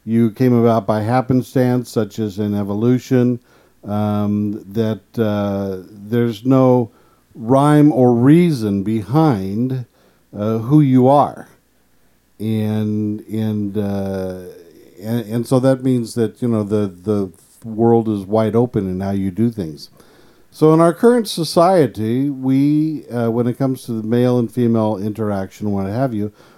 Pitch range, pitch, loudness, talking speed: 105-125 Hz, 115 Hz, -17 LUFS, 140 wpm